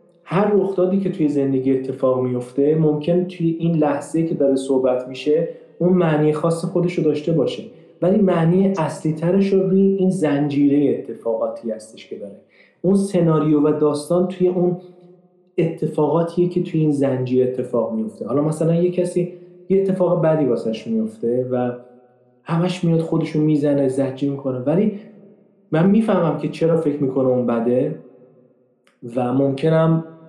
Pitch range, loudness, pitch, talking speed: 135-180 Hz, -19 LUFS, 160 Hz, 145 wpm